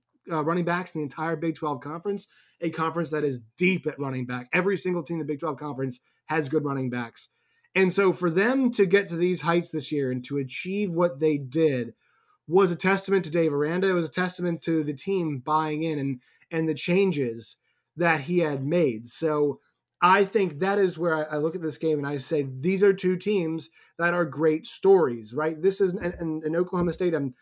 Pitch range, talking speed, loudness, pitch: 150-185 Hz, 220 wpm, -26 LUFS, 165 Hz